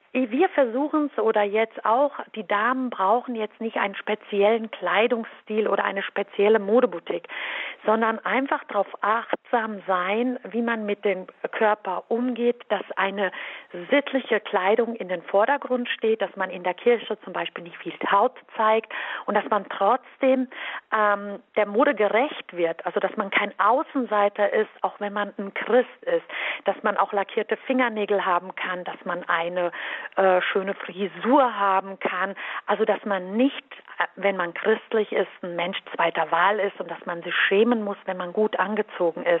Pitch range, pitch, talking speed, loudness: 190-235 Hz, 210 Hz, 165 wpm, -24 LUFS